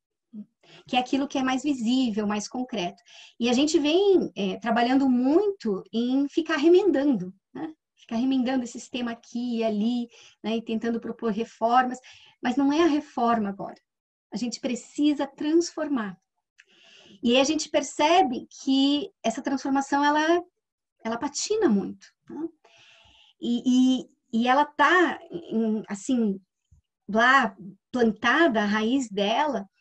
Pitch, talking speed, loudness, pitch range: 255 Hz, 130 wpm, -25 LUFS, 225-295 Hz